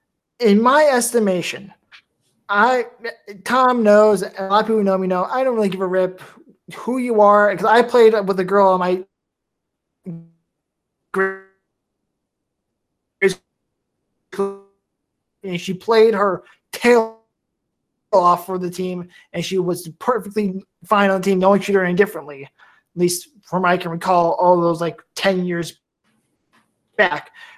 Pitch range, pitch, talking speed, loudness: 180-215 Hz, 195 Hz, 140 wpm, -17 LUFS